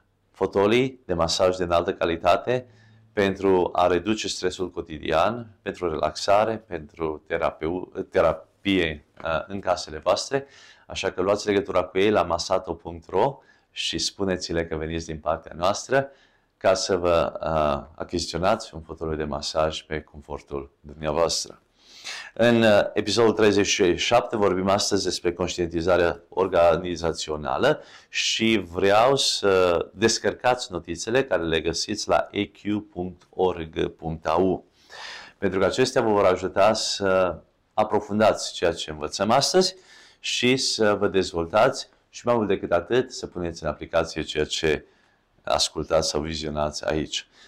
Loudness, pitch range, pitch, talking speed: -24 LUFS, 80-110 Hz, 95 Hz, 120 wpm